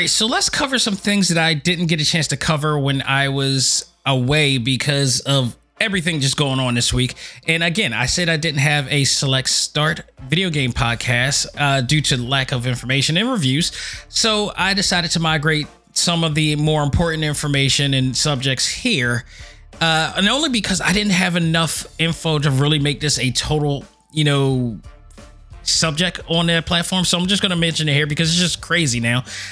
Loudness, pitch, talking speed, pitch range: -17 LUFS, 150 Hz, 190 wpm, 135-170 Hz